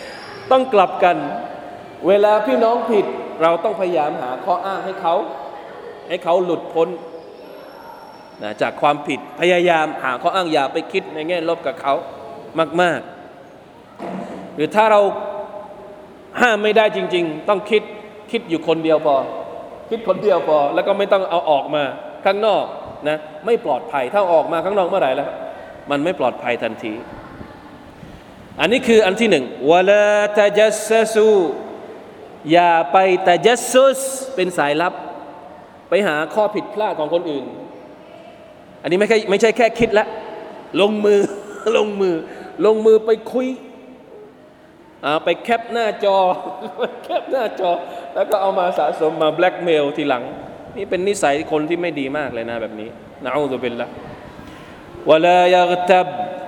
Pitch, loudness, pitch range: 185 Hz, -18 LUFS, 160-215 Hz